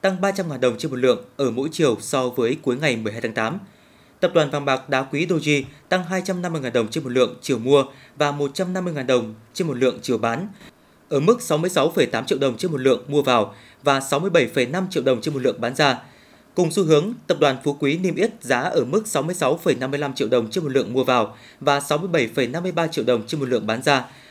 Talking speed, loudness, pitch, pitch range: 215 wpm, -21 LUFS, 145 Hz, 130-180 Hz